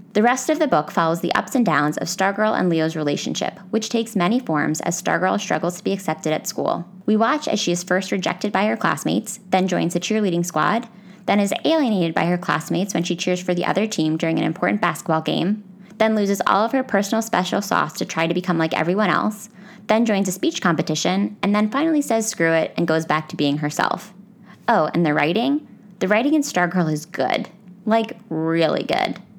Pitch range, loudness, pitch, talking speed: 165-215 Hz, -21 LUFS, 185 Hz, 215 wpm